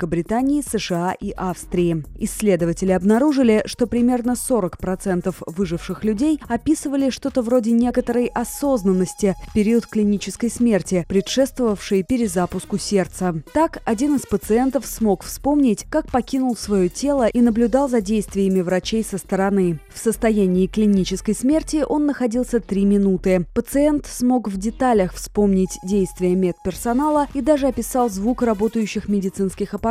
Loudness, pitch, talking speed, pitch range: -20 LUFS, 215 Hz, 125 wpm, 190-250 Hz